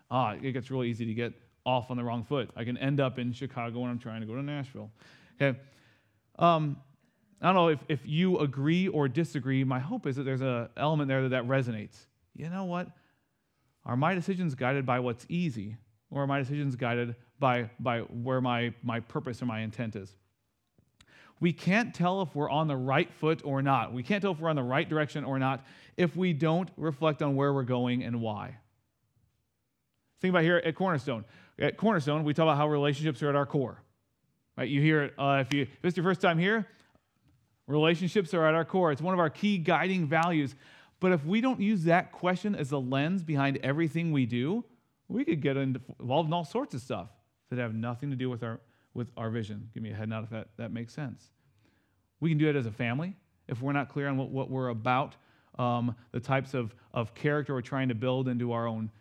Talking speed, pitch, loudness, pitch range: 220 wpm, 135 Hz, -30 LUFS, 120-155 Hz